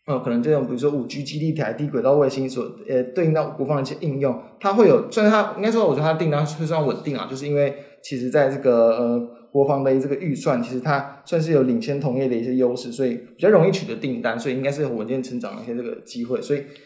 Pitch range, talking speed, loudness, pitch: 125-150 Hz, 400 characters per minute, -22 LUFS, 140 Hz